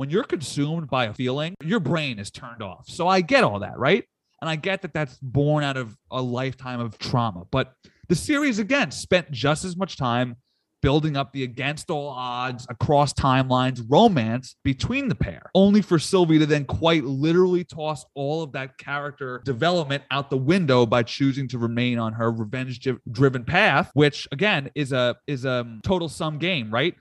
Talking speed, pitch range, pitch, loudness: 190 wpm, 125-165 Hz, 140 Hz, -23 LUFS